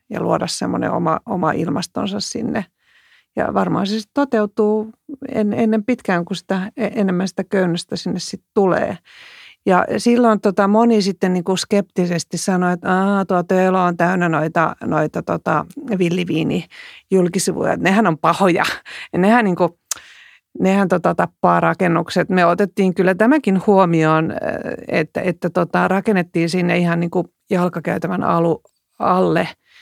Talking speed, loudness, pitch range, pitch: 135 wpm, -18 LUFS, 175-210 Hz, 190 Hz